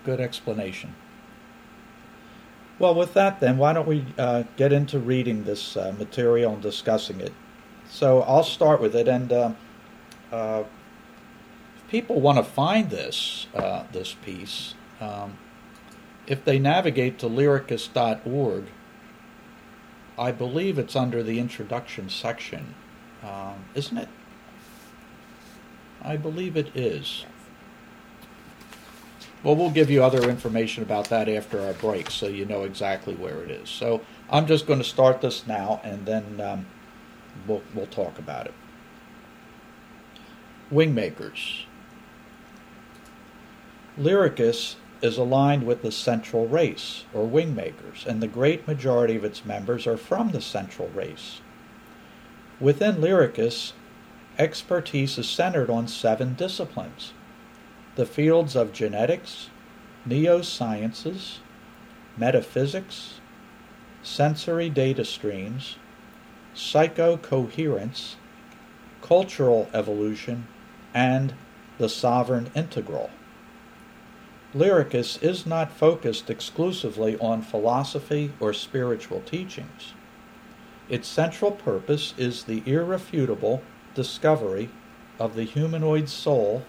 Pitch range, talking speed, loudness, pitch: 115-170 Hz, 110 wpm, -25 LUFS, 135 Hz